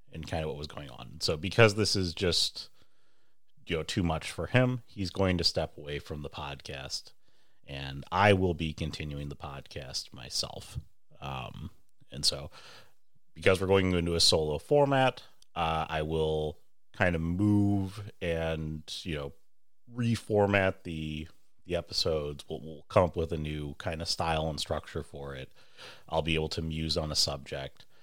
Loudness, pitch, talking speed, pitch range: -30 LUFS, 80 Hz, 170 wpm, 75-95 Hz